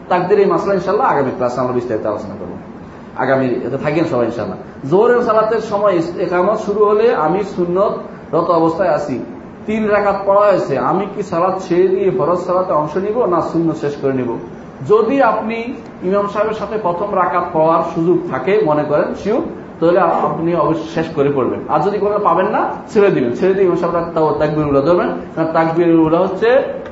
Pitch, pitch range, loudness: 180 Hz, 160-205 Hz, -15 LUFS